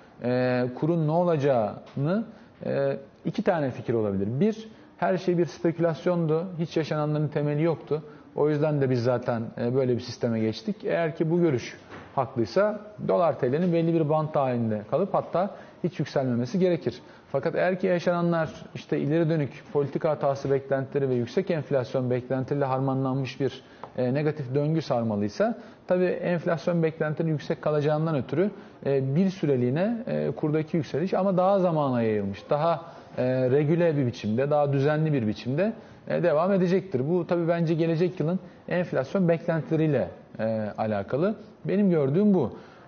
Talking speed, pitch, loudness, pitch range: 135 wpm, 155 Hz, -26 LUFS, 130-175 Hz